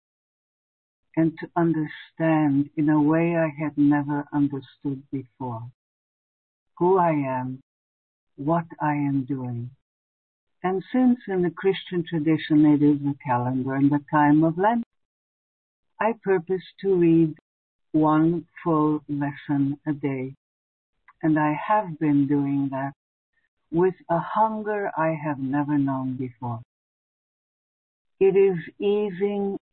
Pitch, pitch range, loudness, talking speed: 150 Hz, 135-170 Hz, -24 LUFS, 120 wpm